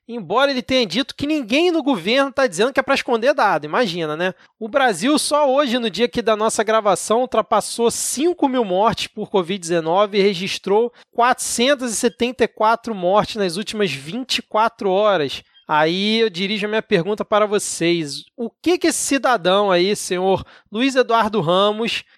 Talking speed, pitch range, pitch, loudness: 160 wpm, 200-250 Hz, 225 Hz, -18 LUFS